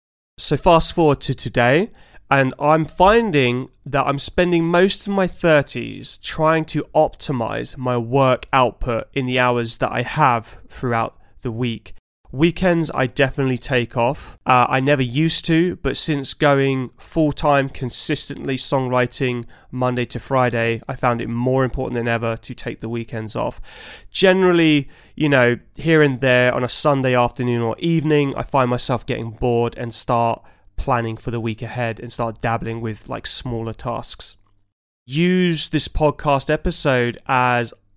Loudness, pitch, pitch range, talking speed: -19 LUFS, 130 Hz, 120-150 Hz, 155 wpm